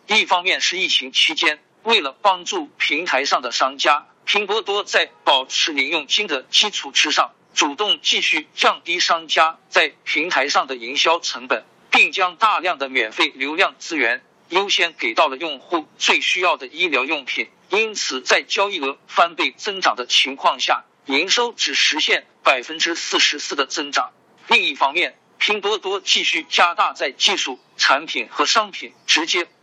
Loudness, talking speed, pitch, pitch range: -18 LUFS, 250 characters per minute, 200 Hz, 165-215 Hz